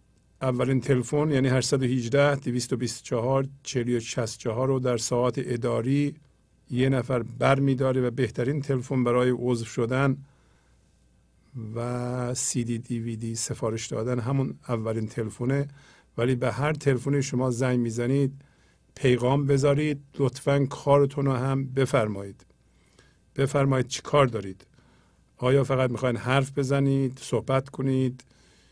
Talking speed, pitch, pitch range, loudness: 120 wpm, 130 Hz, 120-135 Hz, -26 LUFS